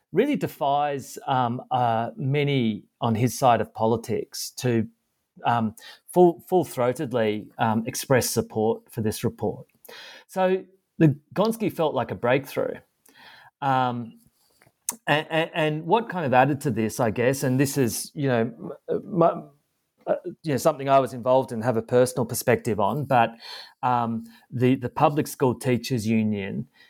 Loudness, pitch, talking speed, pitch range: -24 LUFS, 130 Hz, 145 wpm, 115-150 Hz